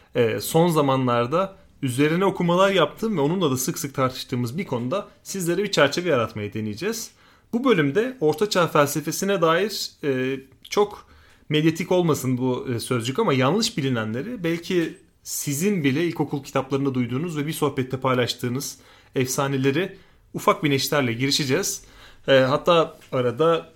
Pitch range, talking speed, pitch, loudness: 130-175 Hz, 120 wpm, 145 Hz, -23 LUFS